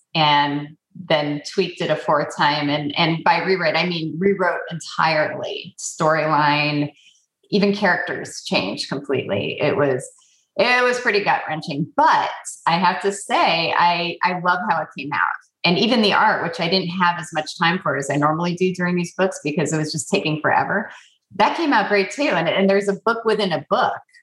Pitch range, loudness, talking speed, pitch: 155-200 Hz, -20 LUFS, 190 wpm, 175 Hz